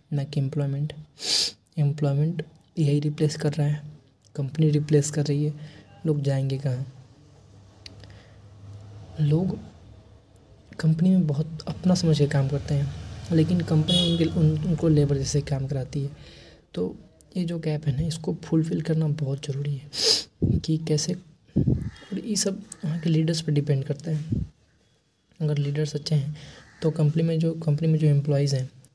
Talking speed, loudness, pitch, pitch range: 150 wpm, -25 LUFS, 150 Hz, 140-160 Hz